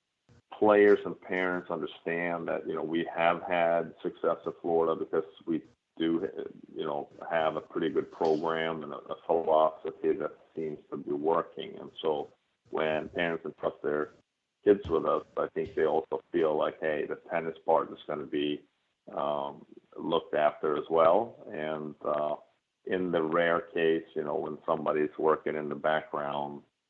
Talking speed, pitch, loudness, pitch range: 165 wpm, 80 Hz, -30 LUFS, 75-90 Hz